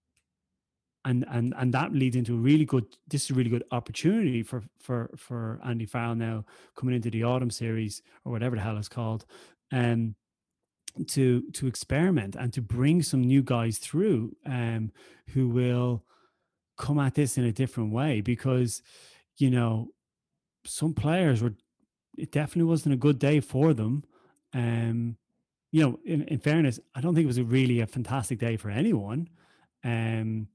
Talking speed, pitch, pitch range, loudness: 170 wpm, 125 Hz, 115-145 Hz, -28 LUFS